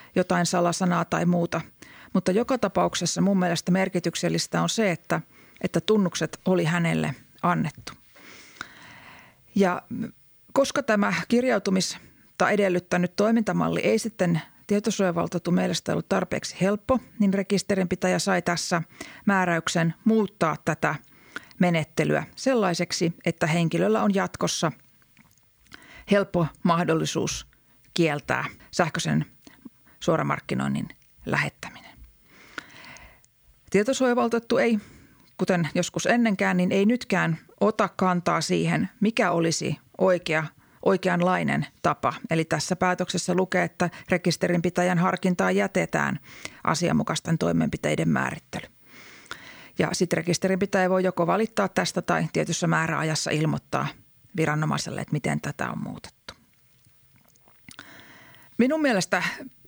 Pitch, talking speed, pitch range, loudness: 180 Hz, 95 wpm, 170-200 Hz, -25 LUFS